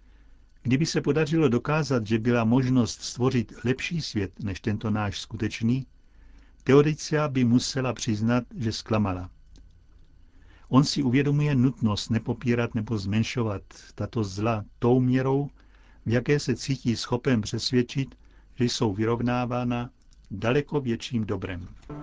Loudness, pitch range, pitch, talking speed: -26 LUFS, 110-130 Hz, 120 Hz, 115 wpm